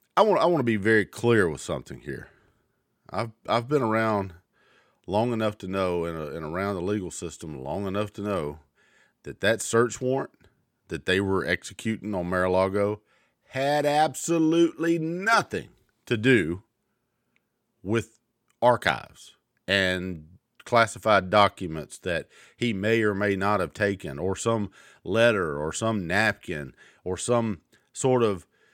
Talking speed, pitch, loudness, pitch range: 135 wpm, 105 Hz, -25 LUFS, 95-120 Hz